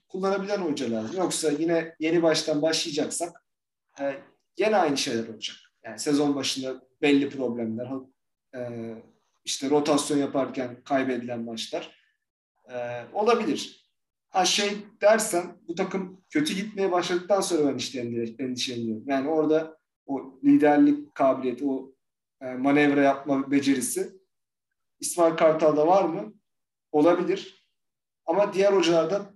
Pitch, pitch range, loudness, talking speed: 150 Hz, 130-180 Hz, -25 LUFS, 110 wpm